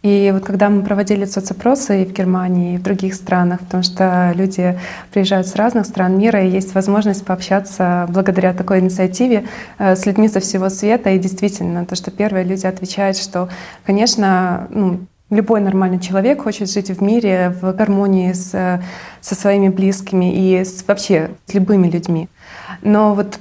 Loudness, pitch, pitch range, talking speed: -16 LUFS, 195 Hz, 185-205 Hz, 165 wpm